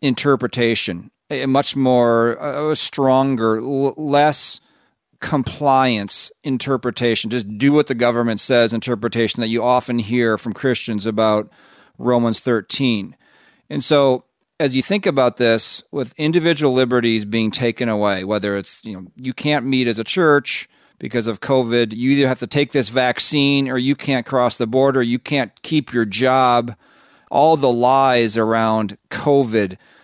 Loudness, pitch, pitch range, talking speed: -18 LUFS, 125 Hz, 115-135 Hz, 145 wpm